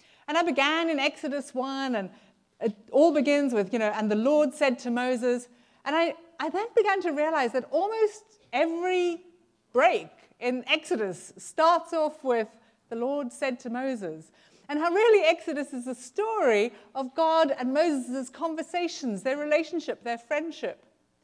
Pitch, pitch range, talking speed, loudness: 280 Hz, 245-325 Hz, 160 wpm, -27 LUFS